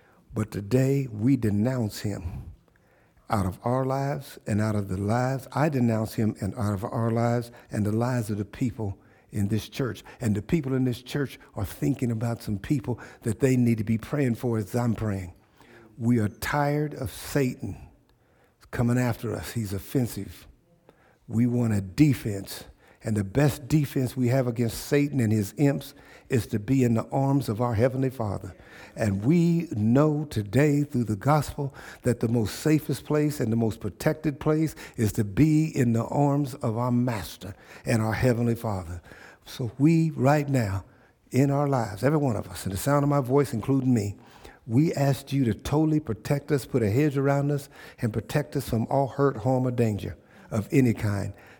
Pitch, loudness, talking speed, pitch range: 120 Hz, -26 LUFS, 185 wpm, 110-140 Hz